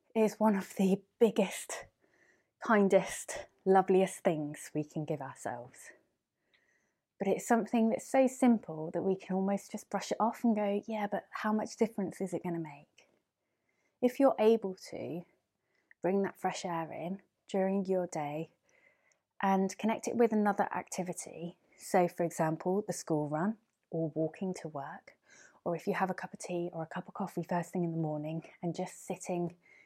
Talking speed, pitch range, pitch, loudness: 175 wpm, 170-210 Hz, 190 Hz, -33 LUFS